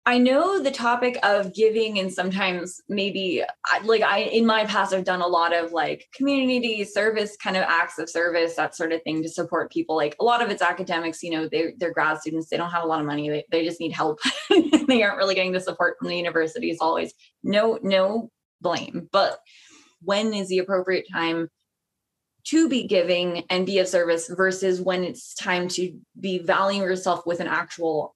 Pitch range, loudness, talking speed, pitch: 170-210 Hz, -23 LUFS, 205 wpm, 185 Hz